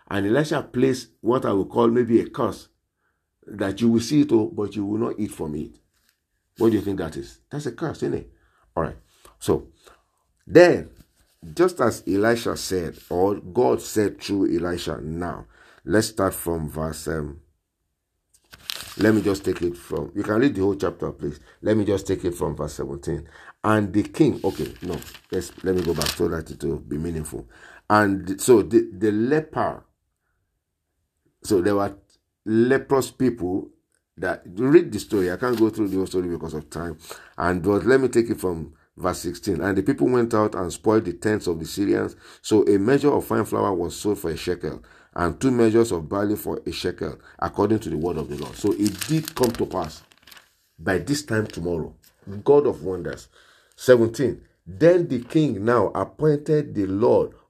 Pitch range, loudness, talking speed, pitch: 85-115 Hz, -23 LUFS, 190 wpm, 100 Hz